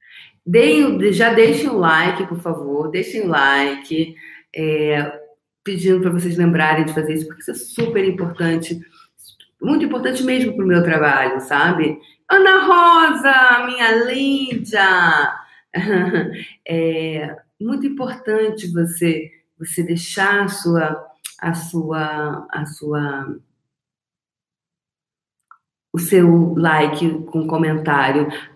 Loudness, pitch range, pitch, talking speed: -16 LUFS, 155-205 Hz, 170 Hz, 110 wpm